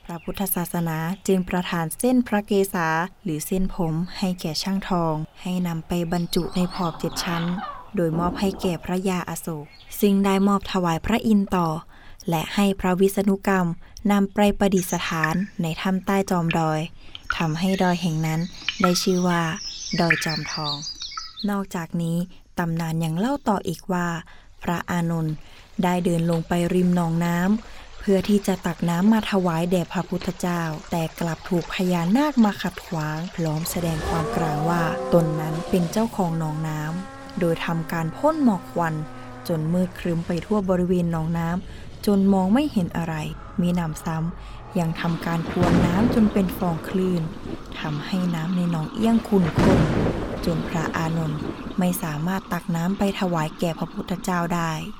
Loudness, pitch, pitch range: -24 LUFS, 175 Hz, 165-195 Hz